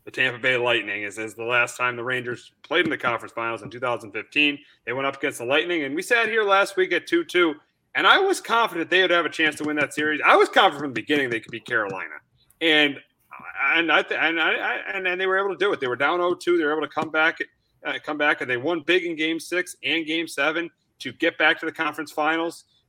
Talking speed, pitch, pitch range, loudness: 260 wpm, 155 Hz, 135-180 Hz, -22 LUFS